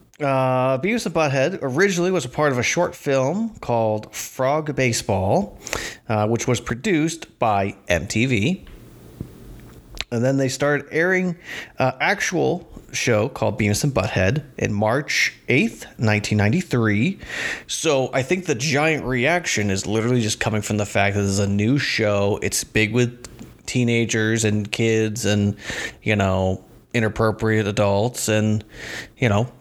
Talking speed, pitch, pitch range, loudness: 140 wpm, 115 Hz, 105-135 Hz, -21 LUFS